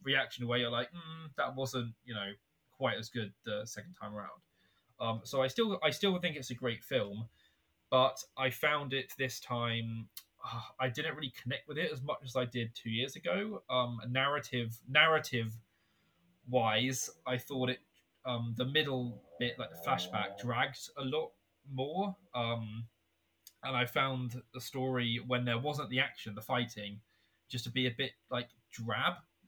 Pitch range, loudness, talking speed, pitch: 115-135 Hz, -35 LUFS, 175 wpm, 125 Hz